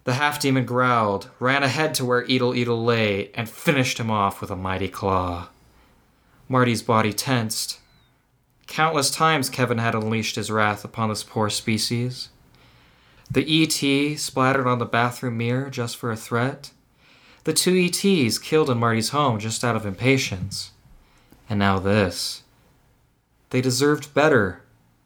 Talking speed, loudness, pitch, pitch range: 145 wpm, -22 LUFS, 125 Hz, 110-135 Hz